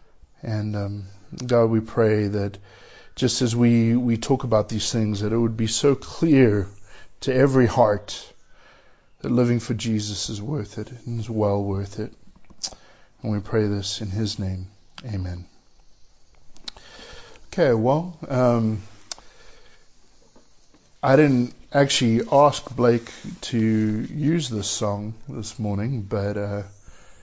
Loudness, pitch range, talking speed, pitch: -22 LUFS, 105-120 Hz, 130 wpm, 110 Hz